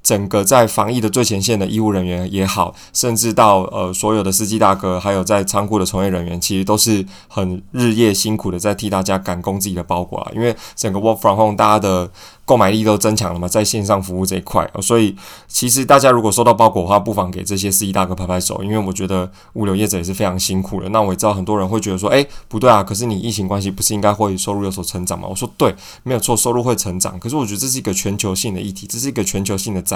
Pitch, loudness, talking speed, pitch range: 100 Hz, -16 LUFS, 420 characters per minute, 95-110 Hz